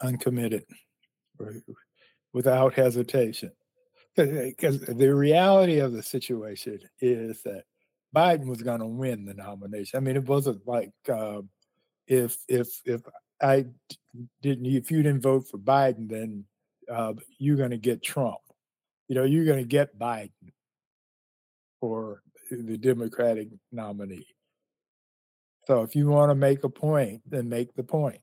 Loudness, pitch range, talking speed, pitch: -26 LUFS, 115-140 Hz, 140 wpm, 125 Hz